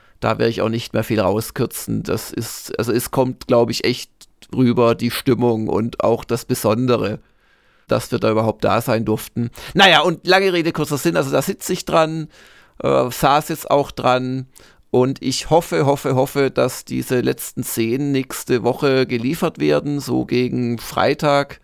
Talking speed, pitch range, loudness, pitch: 170 wpm, 115-140 Hz, -18 LUFS, 125 Hz